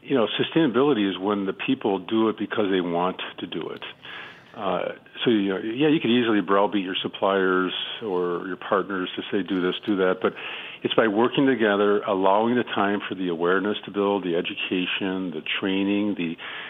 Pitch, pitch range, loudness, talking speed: 100 Hz, 95-105 Hz, -24 LUFS, 190 wpm